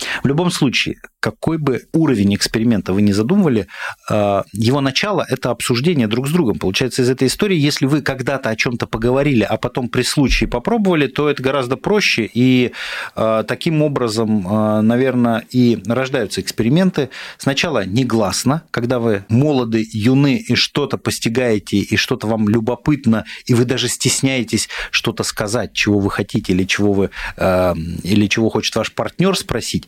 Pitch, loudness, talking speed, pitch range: 120 Hz, -17 LUFS, 160 wpm, 110-135 Hz